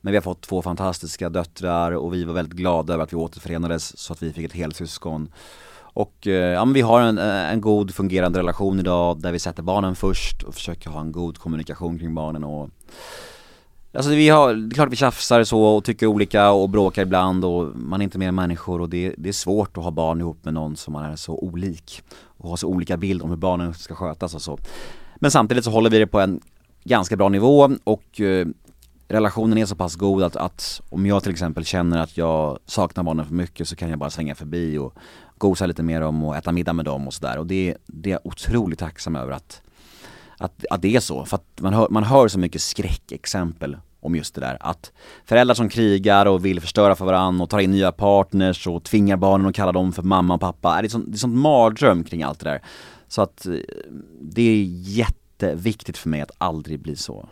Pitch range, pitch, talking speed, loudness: 80-100 Hz, 90 Hz, 230 wpm, -21 LUFS